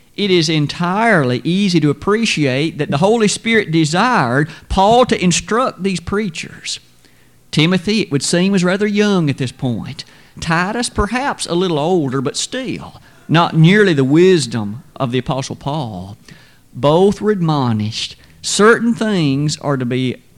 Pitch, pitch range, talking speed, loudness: 165 Hz, 140-200 Hz, 145 wpm, -15 LUFS